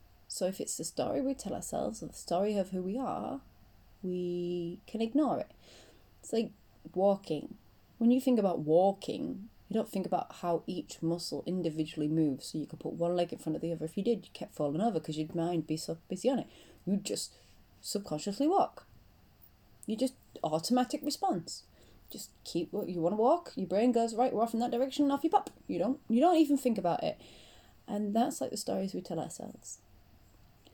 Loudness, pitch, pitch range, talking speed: -33 LUFS, 190 Hz, 155-240 Hz, 205 wpm